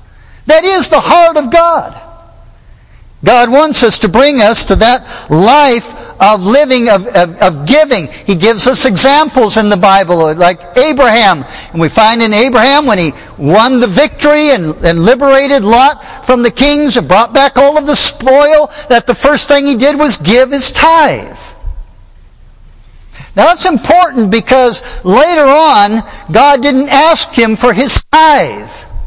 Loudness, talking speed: -6 LUFS, 160 wpm